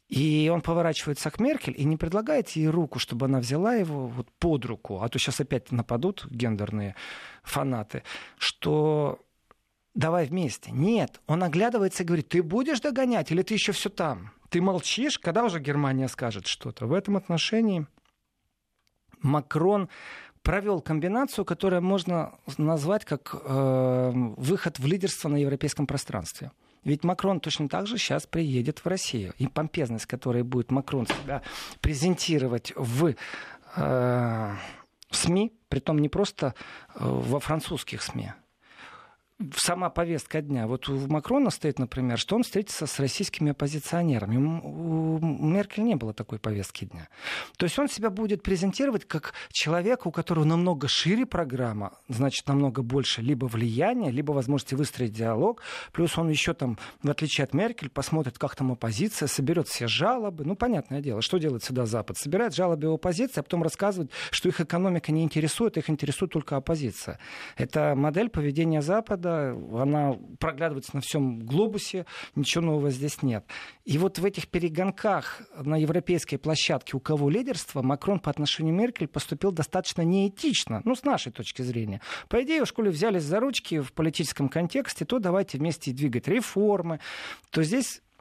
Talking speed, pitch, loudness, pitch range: 150 wpm, 155 Hz, -27 LUFS, 135-185 Hz